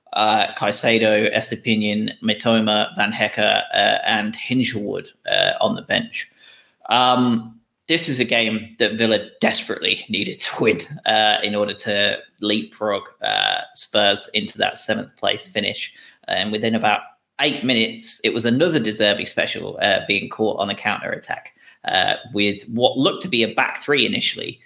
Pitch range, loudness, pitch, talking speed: 105-115 Hz, -19 LUFS, 110 Hz, 150 wpm